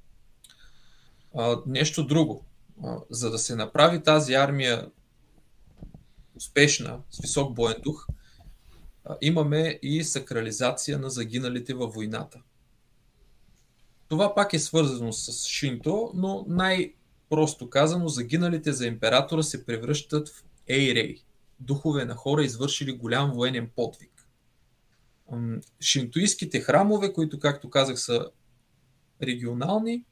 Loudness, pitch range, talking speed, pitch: -26 LUFS, 120-155 Hz, 100 wpm, 140 Hz